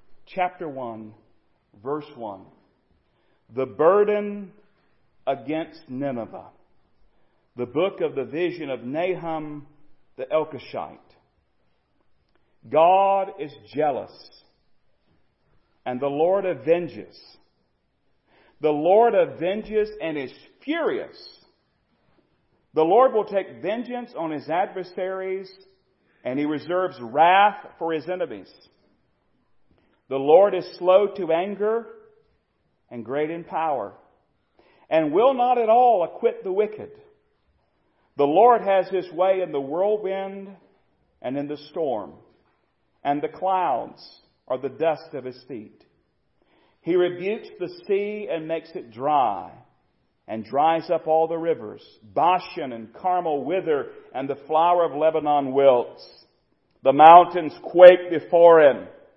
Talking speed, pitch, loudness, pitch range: 115 wpm, 175 Hz, -21 LUFS, 150-195 Hz